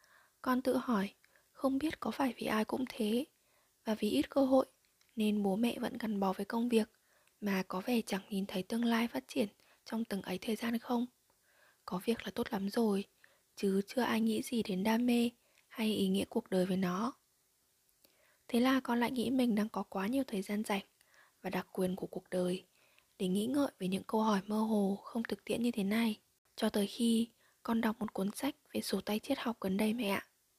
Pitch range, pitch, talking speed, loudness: 200-240 Hz, 220 Hz, 220 wpm, -35 LUFS